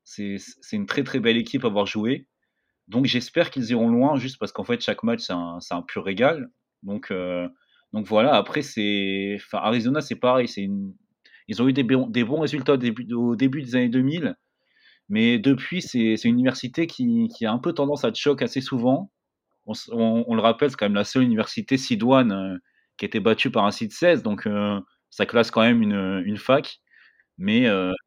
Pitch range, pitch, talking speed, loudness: 110-145 Hz, 125 Hz, 220 wpm, -23 LUFS